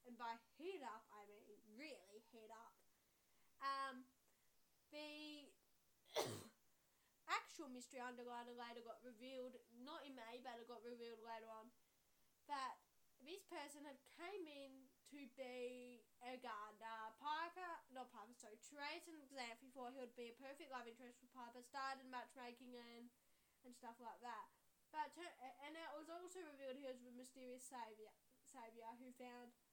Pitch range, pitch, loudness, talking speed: 235-285 Hz, 250 Hz, -55 LUFS, 150 wpm